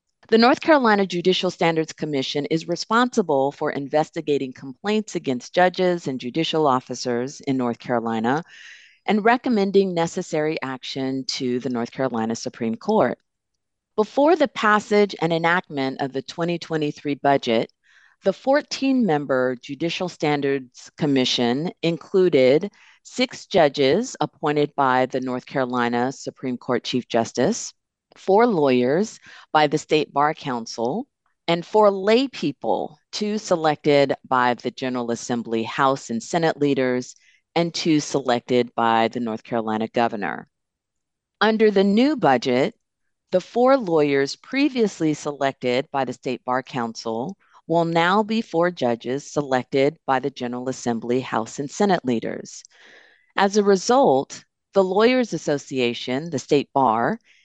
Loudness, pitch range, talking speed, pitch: -22 LUFS, 125-185 Hz, 125 wpm, 145 Hz